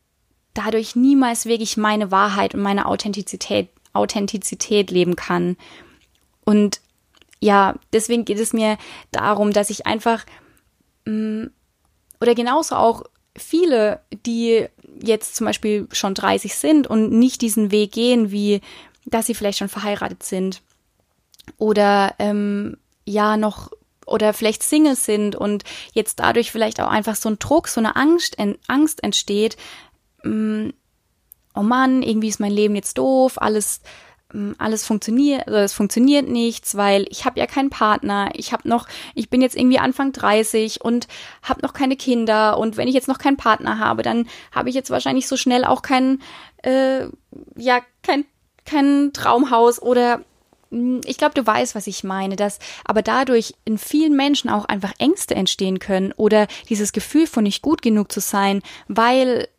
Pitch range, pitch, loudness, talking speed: 210-255 Hz, 220 Hz, -19 LUFS, 155 wpm